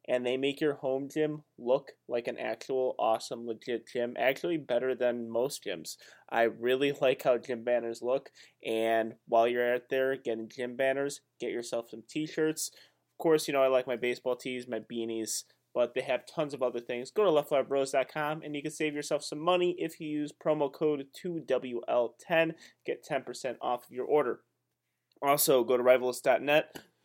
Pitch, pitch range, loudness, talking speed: 130 Hz, 120-150 Hz, -31 LUFS, 180 wpm